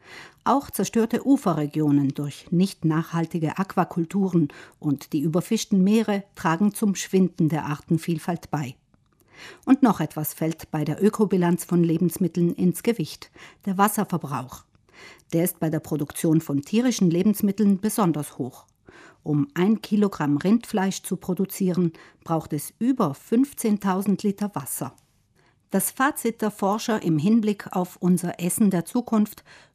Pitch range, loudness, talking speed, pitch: 160-205 Hz, -24 LUFS, 125 wpm, 180 Hz